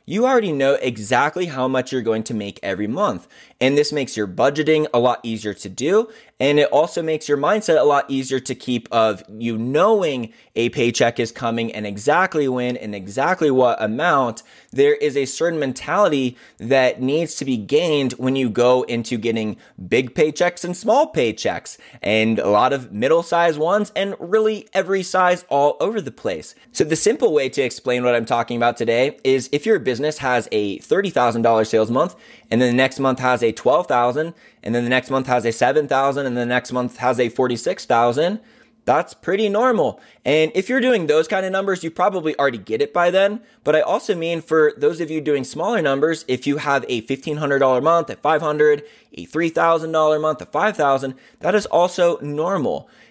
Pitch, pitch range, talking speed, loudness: 140 Hz, 125-170 Hz, 195 wpm, -19 LUFS